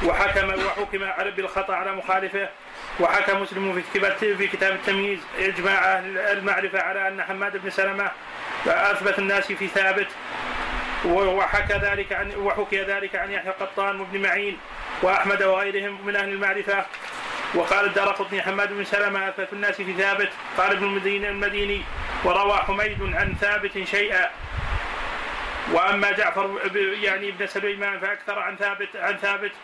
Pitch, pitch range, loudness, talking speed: 200 Hz, 195-200 Hz, -23 LUFS, 130 wpm